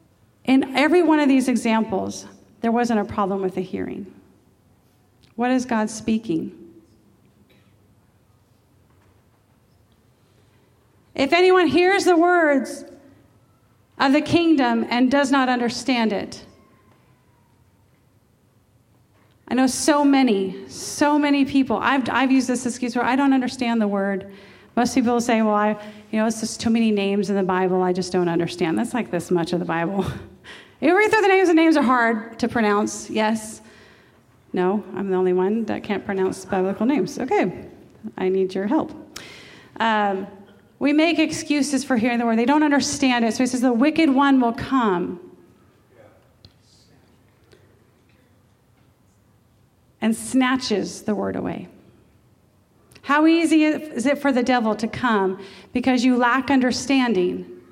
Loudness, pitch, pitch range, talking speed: -20 LUFS, 225 Hz, 180-265 Hz, 145 wpm